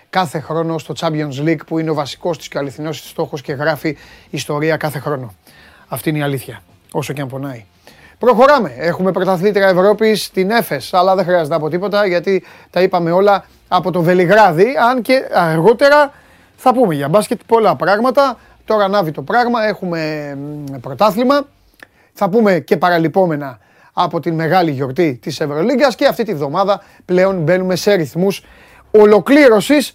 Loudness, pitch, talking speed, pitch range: -14 LUFS, 180 Hz, 160 wpm, 155-210 Hz